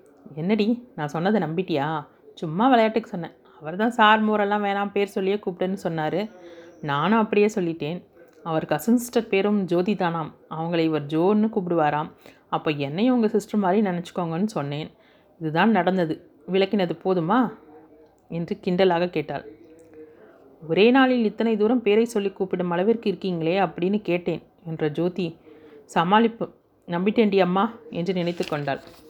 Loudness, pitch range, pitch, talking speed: -23 LUFS, 160-210 Hz, 185 Hz, 130 wpm